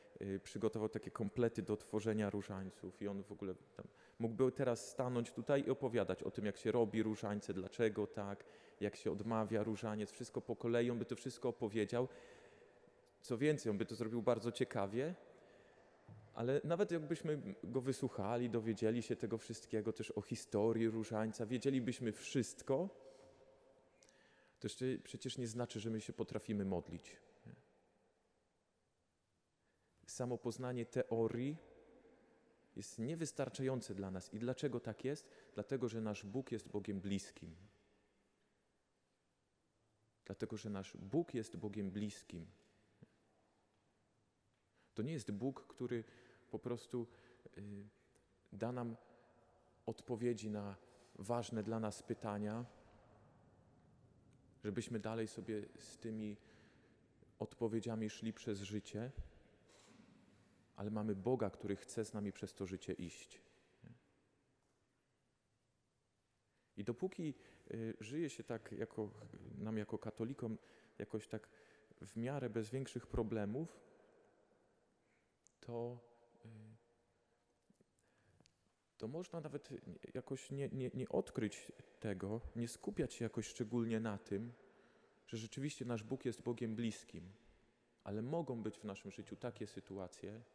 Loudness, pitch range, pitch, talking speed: -43 LUFS, 105-120 Hz, 115 Hz, 115 wpm